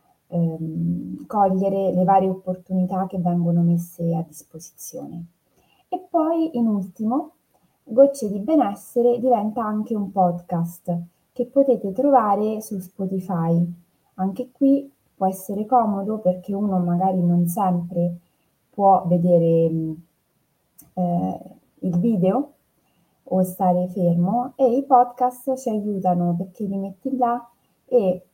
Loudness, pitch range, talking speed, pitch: -22 LUFS, 175-235 Hz, 115 wpm, 190 Hz